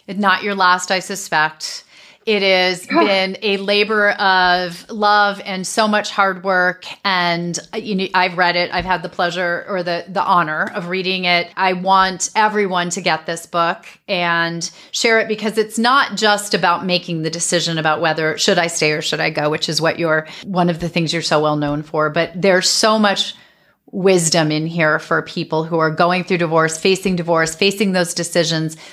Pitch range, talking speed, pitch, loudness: 170-195 Hz, 190 wpm, 180 Hz, -17 LUFS